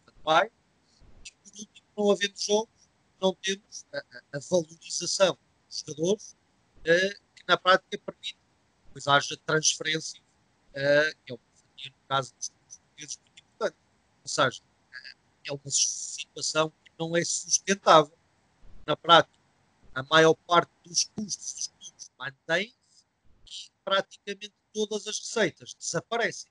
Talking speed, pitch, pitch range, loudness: 135 wpm, 165 Hz, 140-195 Hz, -26 LUFS